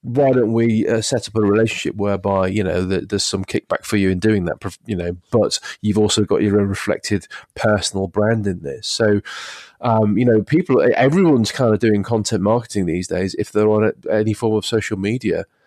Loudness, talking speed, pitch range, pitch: -18 LUFS, 210 wpm, 100-110 Hz, 105 Hz